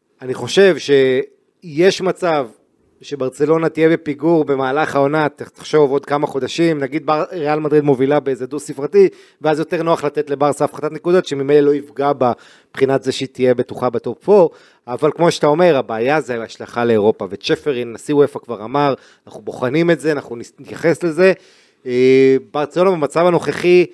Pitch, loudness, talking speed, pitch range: 145 Hz, -16 LUFS, 155 wpm, 135-165 Hz